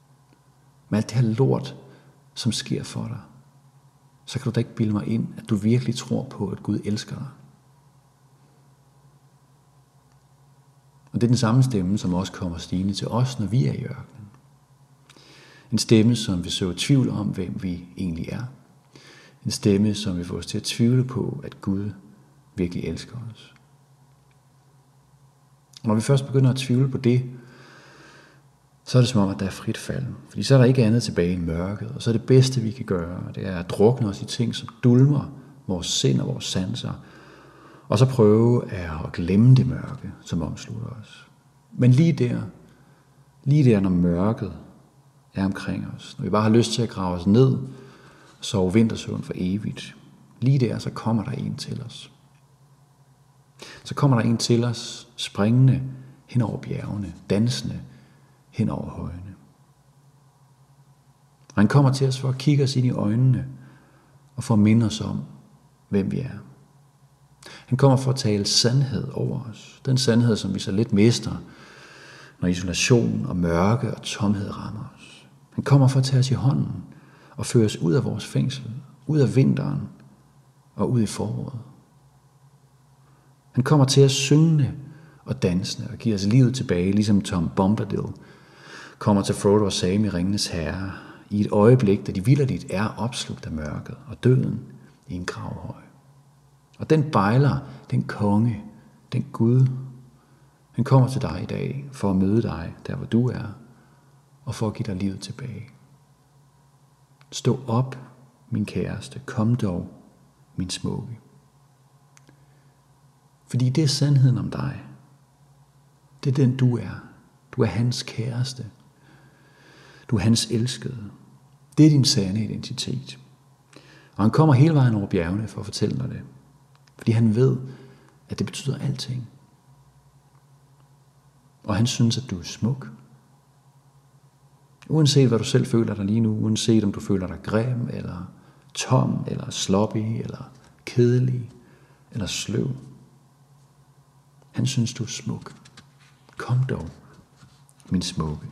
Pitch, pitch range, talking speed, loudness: 130 Hz, 110-140 Hz, 160 wpm, -23 LUFS